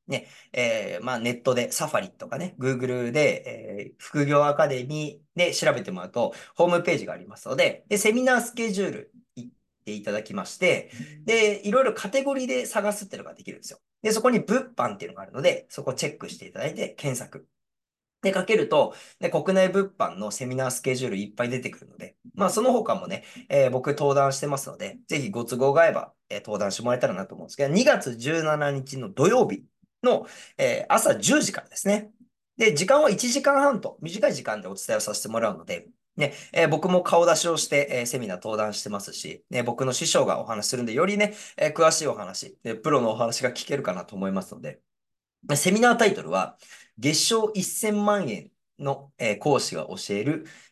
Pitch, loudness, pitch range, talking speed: 165 Hz, -25 LUFS, 130-215 Hz, 395 characters per minute